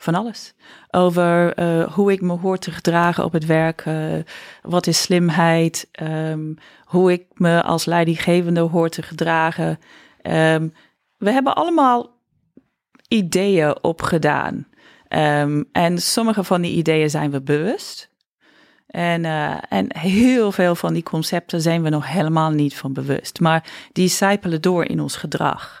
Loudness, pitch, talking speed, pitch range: -19 LUFS, 170 Hz, 145 wpm, 160-185 Hz